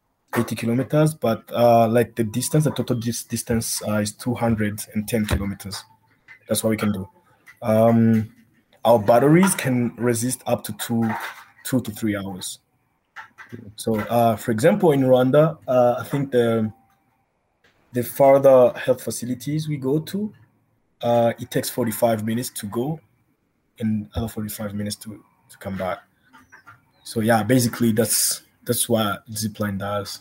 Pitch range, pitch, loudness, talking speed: 110-125 Hz, 115 Hz, -21 LUFS, 140 wpm